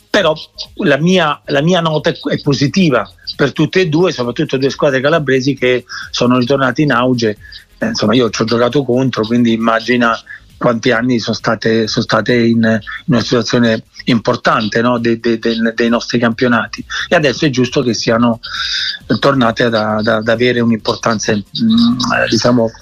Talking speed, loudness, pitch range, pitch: 160 wpm, -13 LUFS, 115-140 Hz, 120 Hz